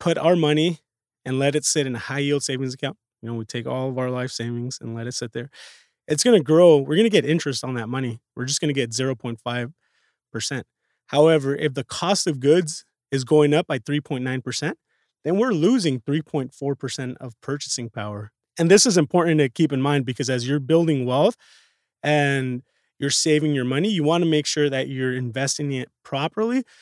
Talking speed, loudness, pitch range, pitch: 205 wpm, -22 LUFS, 130-155 Hz, 140 Hz